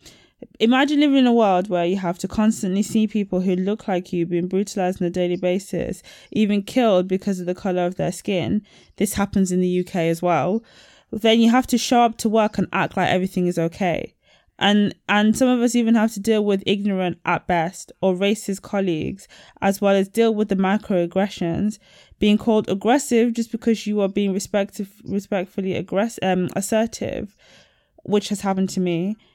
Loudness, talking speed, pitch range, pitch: -21 LUFS, 190 wpm, 180-215 Hz, 195 Hz